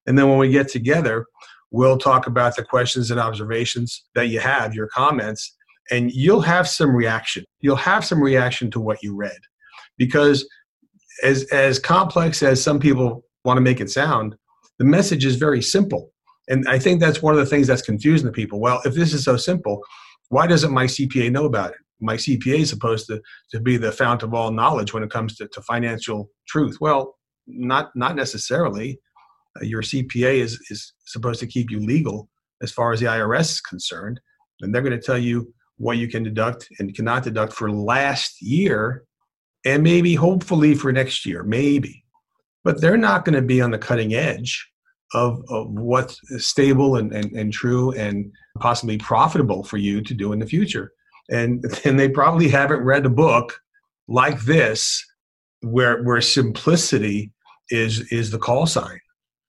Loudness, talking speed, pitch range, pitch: -19 LUFS, 185 wpm, 115-145 Hz, 125 Hz